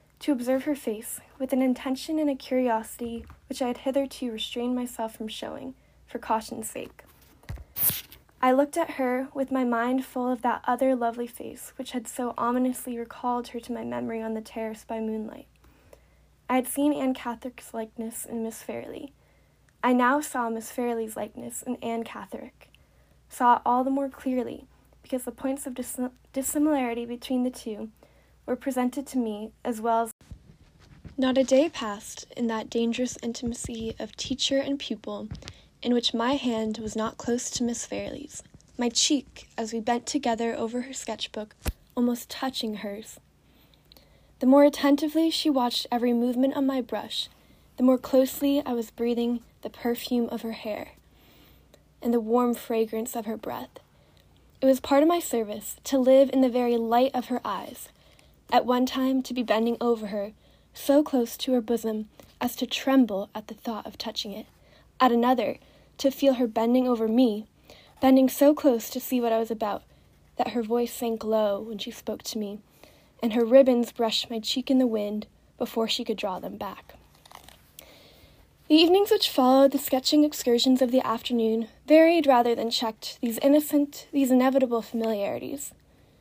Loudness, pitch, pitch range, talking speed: -26 LUFS, 245 Hz, 230-265 Hz, 175 wpm